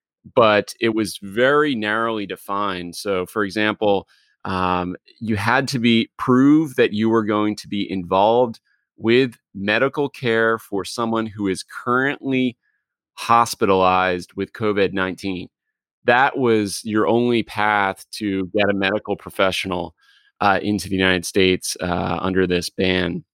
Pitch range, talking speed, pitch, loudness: 95-115 Hz, 135 wpm, 100 Hz, -20 LUFS